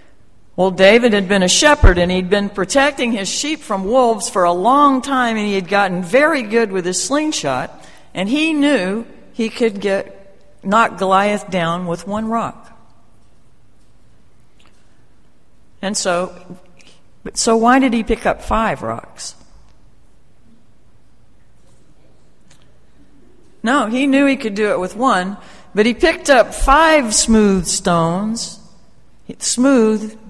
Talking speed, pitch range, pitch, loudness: 130 wpm, 190-250 Hz, 215 Hz, -15 LUFS